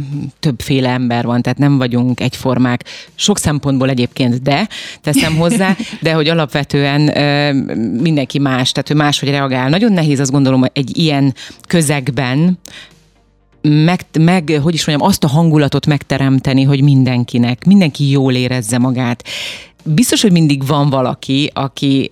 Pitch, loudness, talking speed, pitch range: 140 Hz, -13 LUFS, 140 wpm, 130-155 Hz